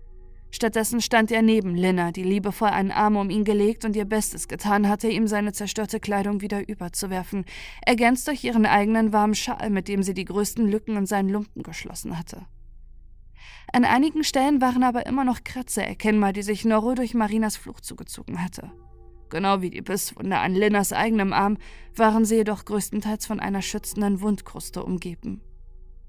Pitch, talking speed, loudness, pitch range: 210 Hz, 170 wpm, -23 LUFS, 195-220 Hz